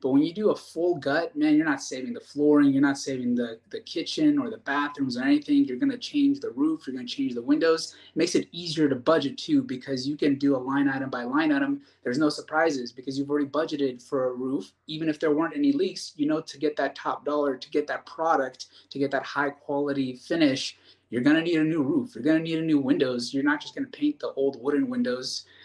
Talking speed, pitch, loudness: 255 wpm, 150 Hz, -26 LUFS